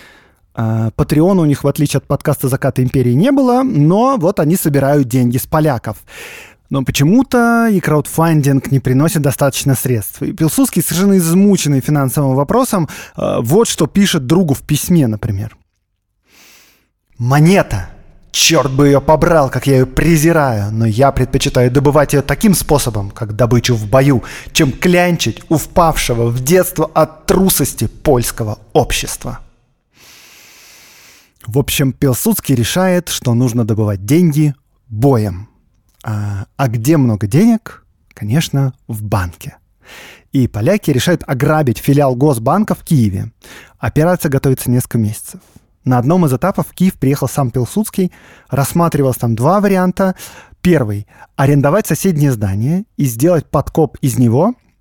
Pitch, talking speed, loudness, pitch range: 140 Hz, 130 wpm, -13 LUFS, 120-165 Hz